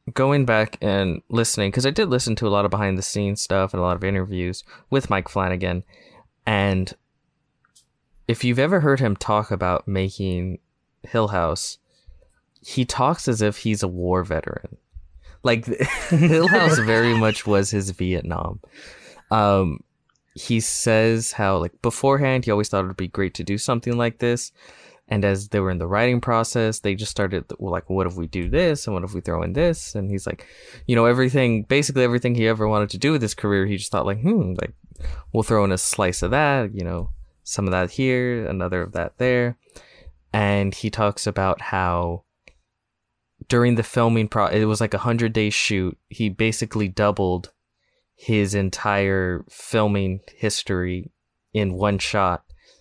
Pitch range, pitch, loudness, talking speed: 95-115 Hz, 105 Hz, -22 LUFS, 180 wpm